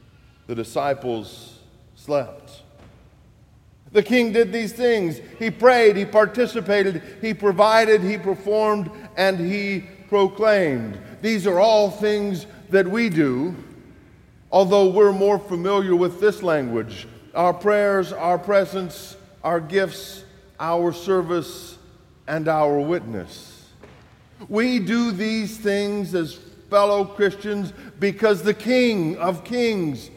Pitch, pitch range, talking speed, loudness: 195 Hz, 165-210 Hz, 110 wpm, -20 LUFS